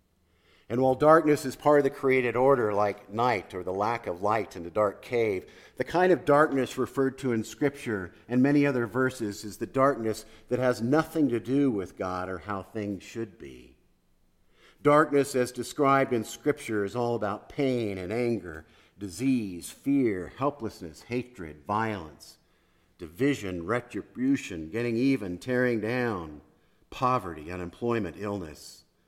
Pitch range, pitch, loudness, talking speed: 100-135 Hz, 120 Hz, -28 LUFS, 150 wpm